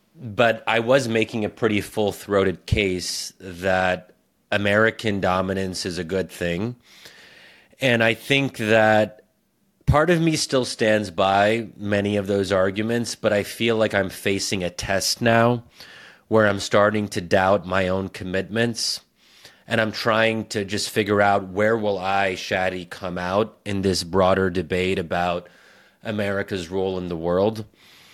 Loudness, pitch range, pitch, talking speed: -22 LUFS, 95-110 Hz, 100 Hz, 145 wpm